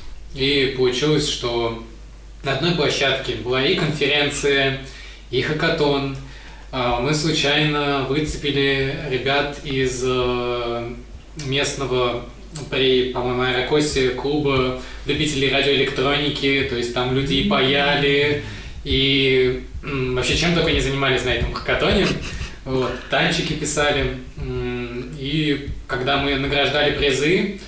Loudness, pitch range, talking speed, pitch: -20 LUFS, 125-145 Hz, 100 wpm, 135 Hz